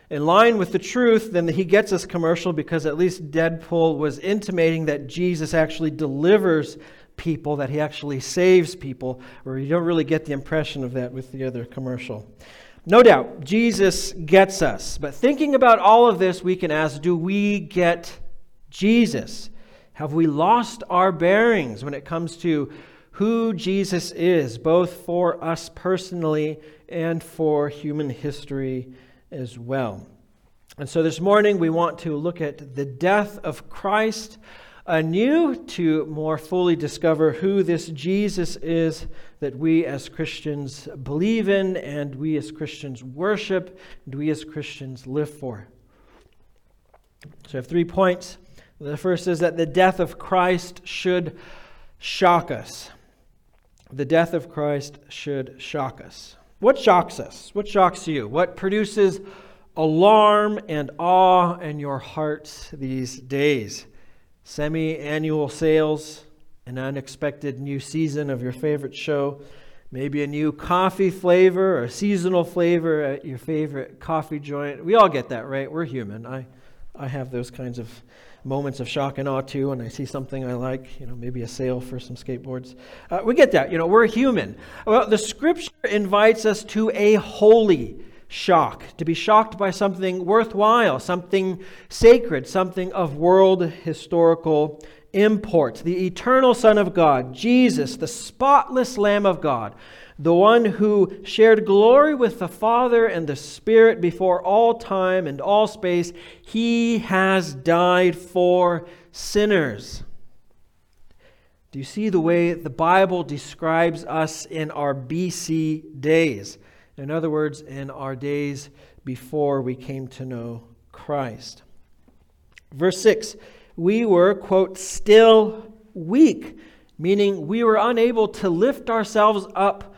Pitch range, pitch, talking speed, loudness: 145-190 Hz, 165 Hz, 145 wpm, -20 LUFS